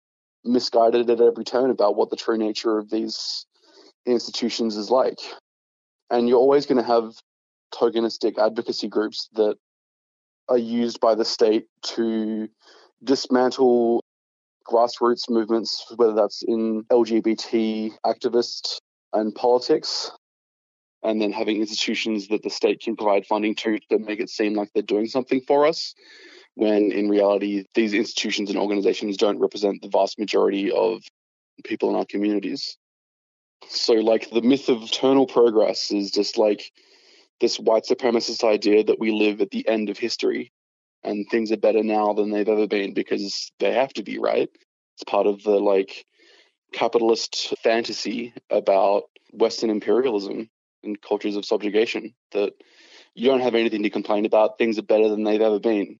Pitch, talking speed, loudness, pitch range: 110 Hz, 155 wpm, -22 LUFS, 105-120 Hz